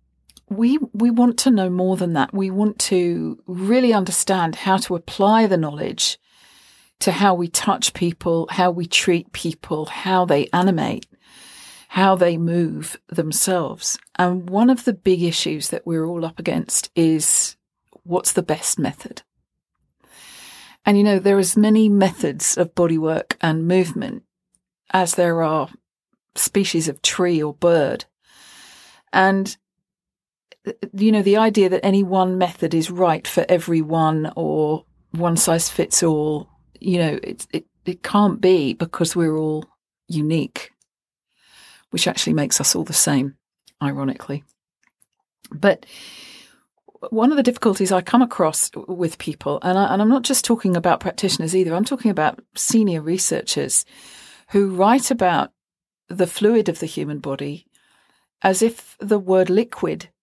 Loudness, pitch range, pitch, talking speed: -19 LUFS, 165-200 Hz, 180 Hz, 145 wpm